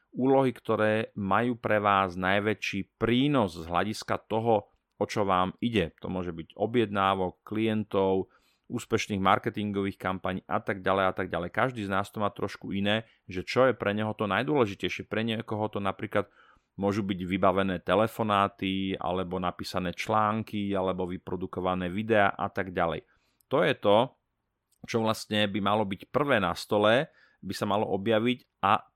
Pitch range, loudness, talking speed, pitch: 95-110 Hz, -28 LUFS, 155 wpm, 100 Hz